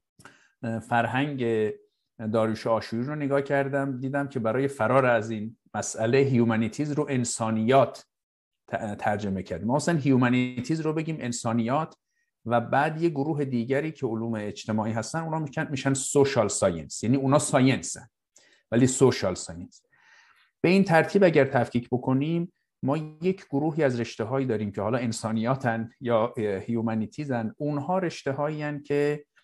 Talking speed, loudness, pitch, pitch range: 135 wpm, -26 LUFS, 130 Hz, 115-145 Hz